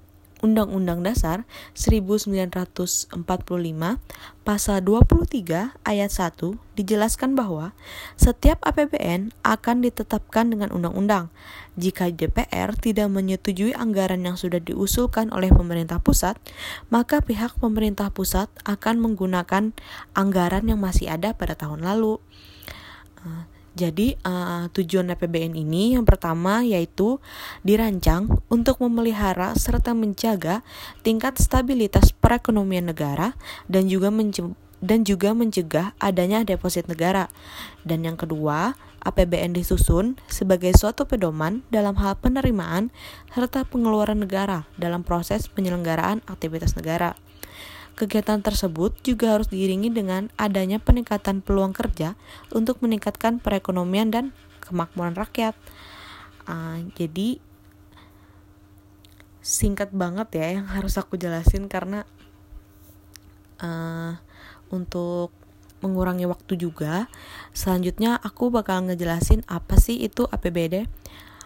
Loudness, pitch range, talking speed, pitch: -23 LUFS, 170-215 Hz, 105 wpm, 190 Hz